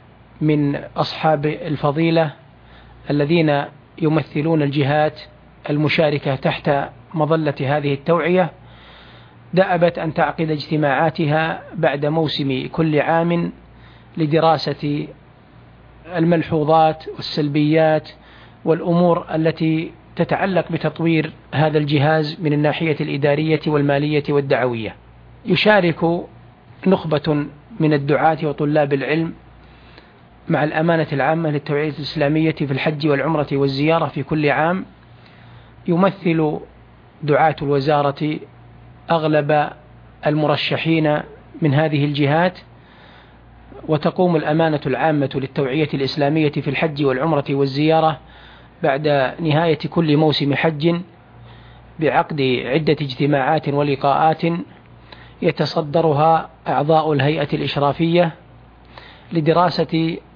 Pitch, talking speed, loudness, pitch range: 155 Hz, 80 wpm, -18 LUFS, 145-160 Hz